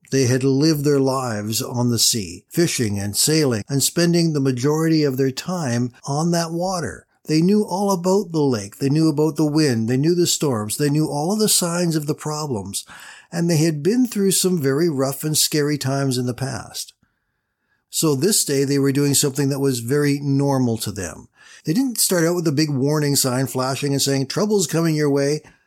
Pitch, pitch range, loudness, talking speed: 145 Hz, 135-165 Hz, -19 LUFS, 205 wpm